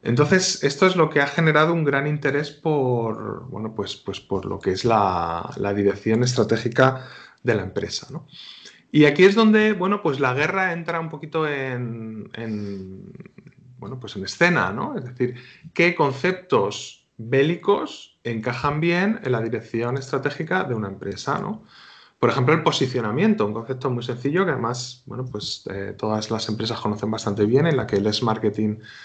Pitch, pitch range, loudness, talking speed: 125 Hz, 110-155 Hz, -22 LUFS, 175 wpm